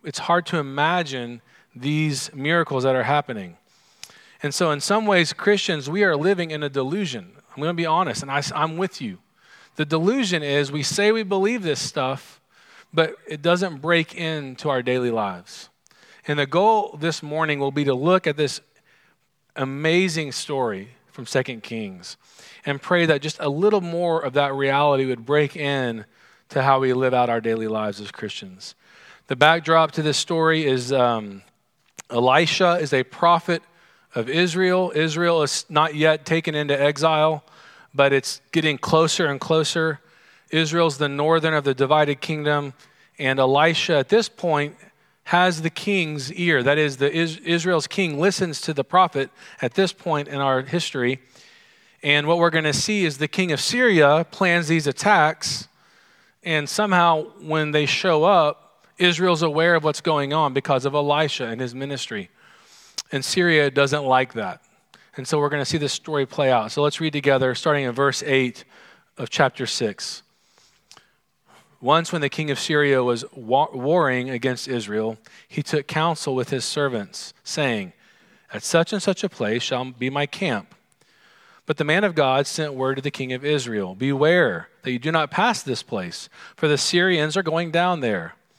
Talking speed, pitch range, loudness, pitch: 175 wpm, 135-170 Hz, -21 LUFS, 150 Hz